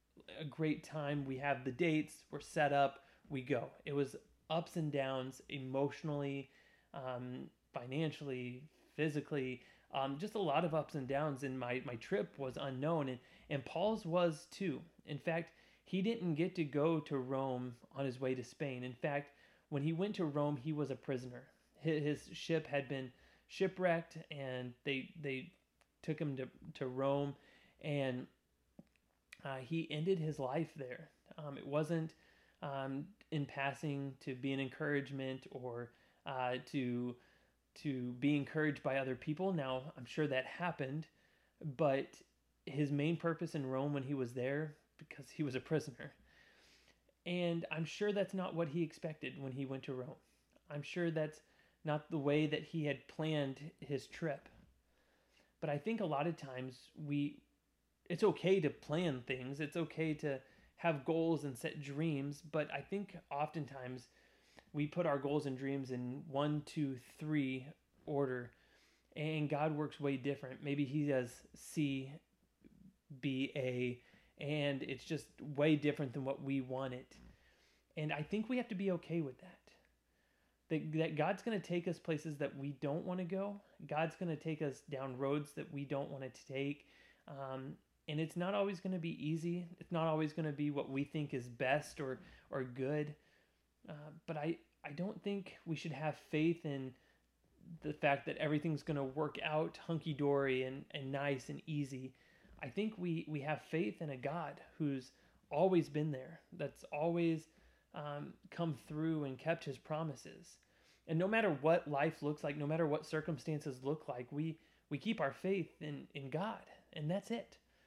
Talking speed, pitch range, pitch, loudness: 175 wpm, 135-160 Hz, 150 Hz, -40 LUFS